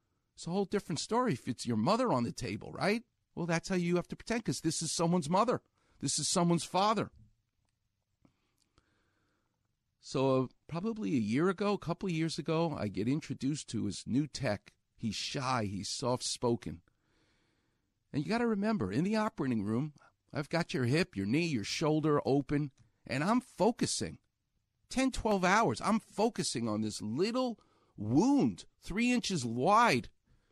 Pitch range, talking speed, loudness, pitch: 115-190 Hz, 165 wpm, -33 LUFS, 155 Hz